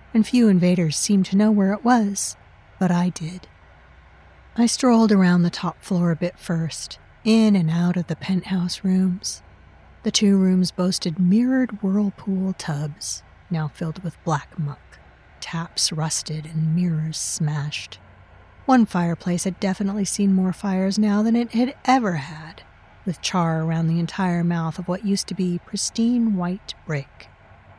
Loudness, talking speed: -22 LUFS, 155 wpm